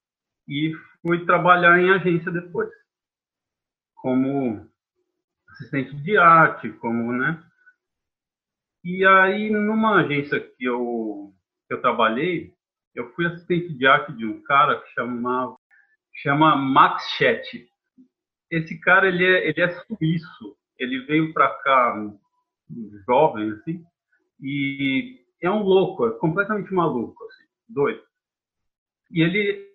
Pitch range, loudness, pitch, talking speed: 135-200 Hz, -20 LUFS, 170 Hz, 120 wpm